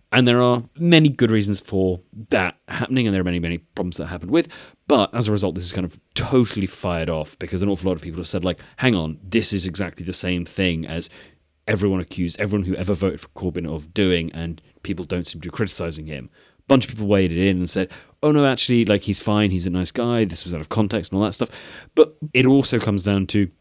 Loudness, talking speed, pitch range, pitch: -21 LUFS, 250 wpm, 90-110 Hz, 95 Hz